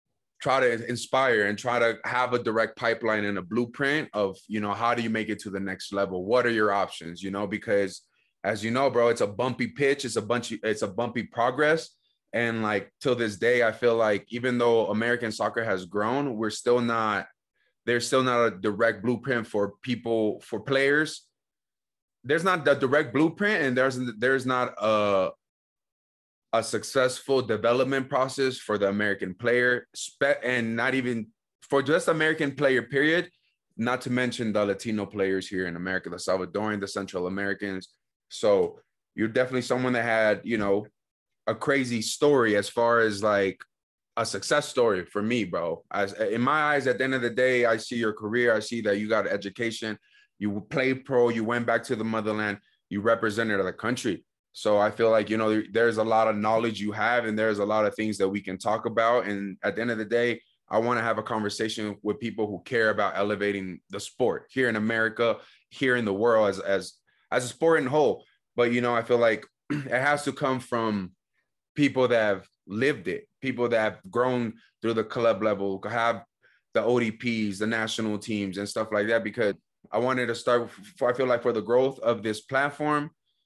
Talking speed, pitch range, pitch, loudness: 200 wpm, 105-125 Hz, 115 Hz, -26 LUFS